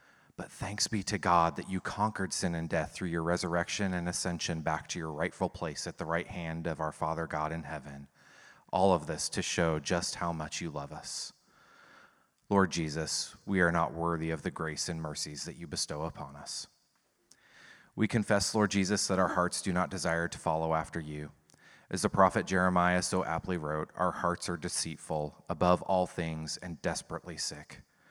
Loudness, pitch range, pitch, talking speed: -32 LUFS, 80-95 Hz, 85 Hz, 190 wpm